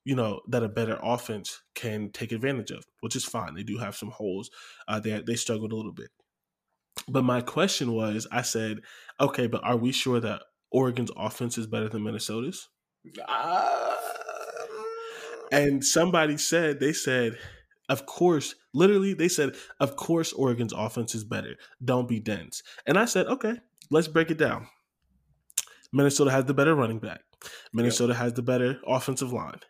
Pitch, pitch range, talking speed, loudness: 125 Hz, 115-150 Hz, 165 wpm, -27 LUFS